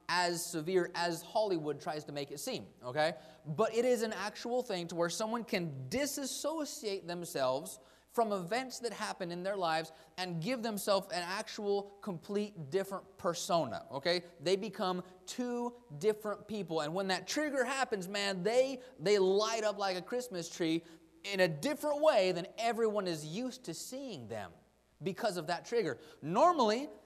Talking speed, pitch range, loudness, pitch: 160 wpm, 170-235 Hz, -35 LUFS, 195 Hz